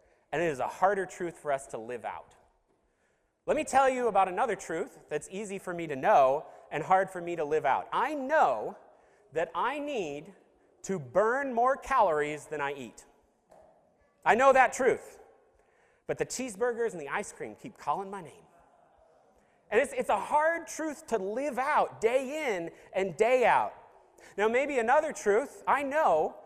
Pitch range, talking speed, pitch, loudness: 185-290 Hz, 175 wpm, 235 Hz, -29 LUFS